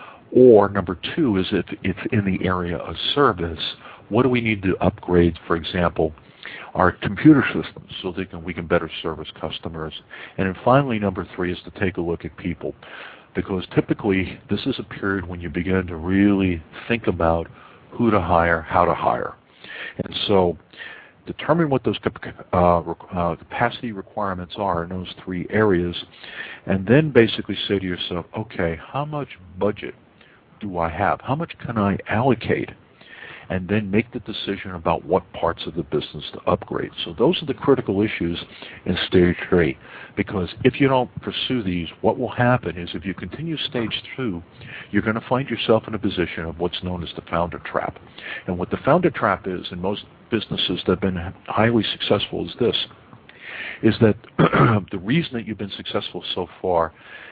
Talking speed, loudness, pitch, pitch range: 175 wpm, -22 LUFS, 95 Hz, 90-115 Hz